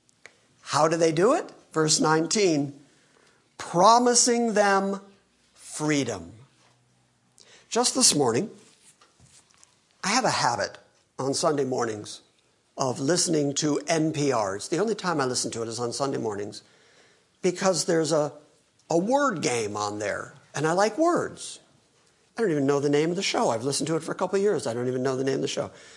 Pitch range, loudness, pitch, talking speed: 135-185 Hz, -24 LUFS, 150 Hz, 170 wpm